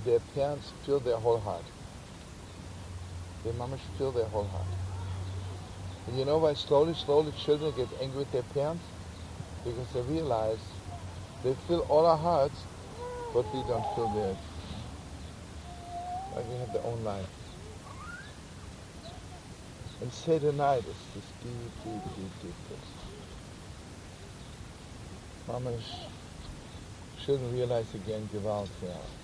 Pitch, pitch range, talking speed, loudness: 105 Hz, 90-135 Hz, 120 wpm, -33 LUFS